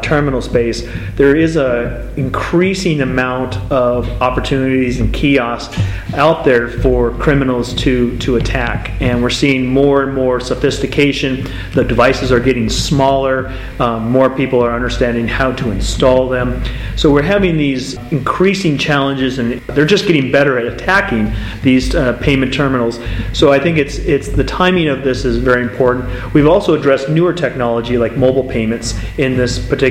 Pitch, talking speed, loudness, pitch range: 130 Hz, 160 wpm, -14 LUFS, 120-140 Hz